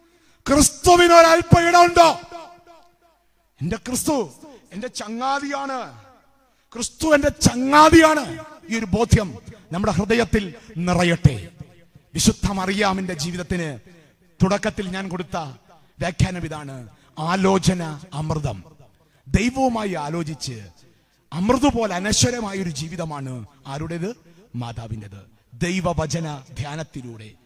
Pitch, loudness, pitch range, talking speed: 185 Hz, -19 LUFS, 155-255 Hz, 75 wpm